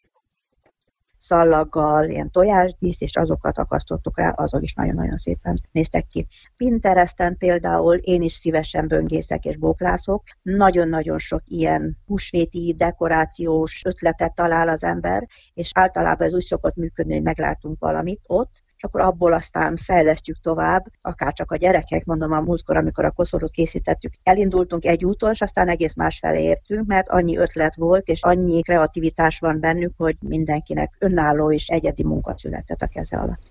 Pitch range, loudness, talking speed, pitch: 150-180 Hz, -20 LUFS, 150 wpm, 165 Hz